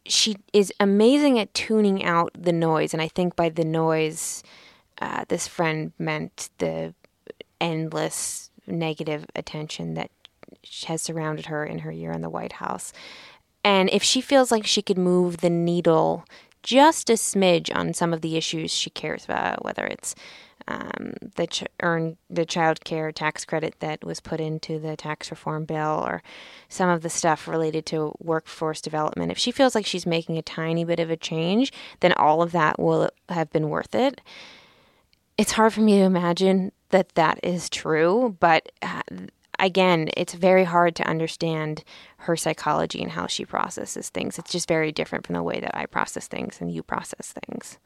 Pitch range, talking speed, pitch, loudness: 155-190 Hz, 180 wpm, 165 Hz, -24 LUFS